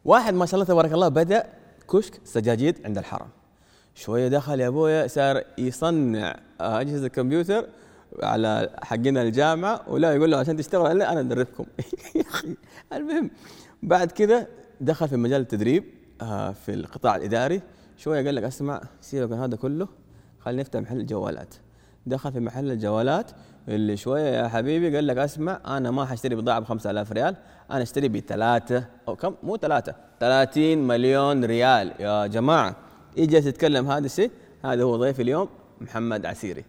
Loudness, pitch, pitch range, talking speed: -24 LUFS, 135 Hz, 120-160 Hz, 155 wpm